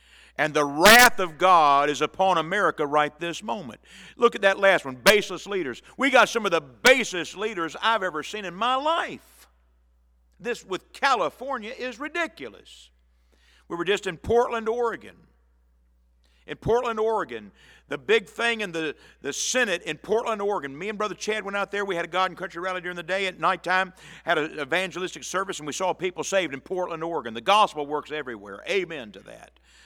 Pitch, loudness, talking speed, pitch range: 185 Hz, -24 LUFS, 185 wpm, 150-215 Hz